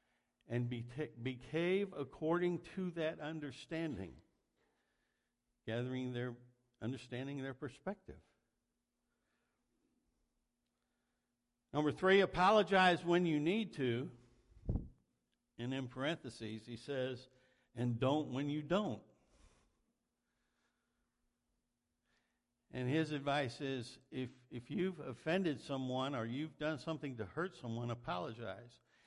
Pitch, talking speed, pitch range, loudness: 135 Hz, 95 wpm, 120-160 Hz, -39 LUFS